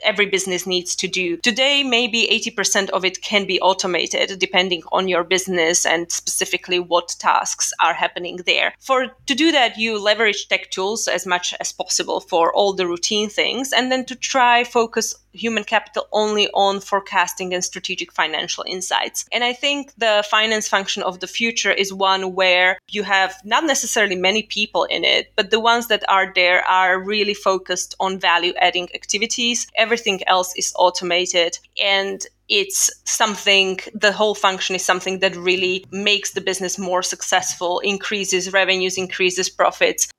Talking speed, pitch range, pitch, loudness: 165 wpm, 185-215 Hz, 195 Hz, -18 LUFS